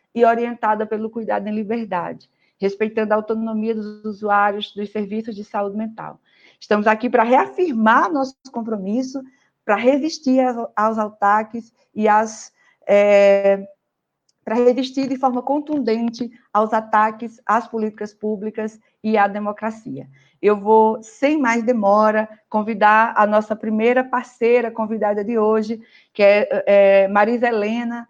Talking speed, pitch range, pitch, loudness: 130 wpm, 210-235 Hz, 220 Hz, -18 LUFS